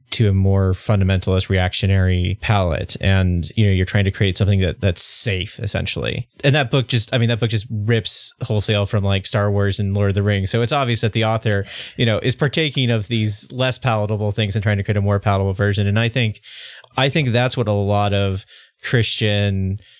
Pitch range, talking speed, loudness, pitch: 100-115 Hz, 215 wpm, -19 LUFS, 105 Hz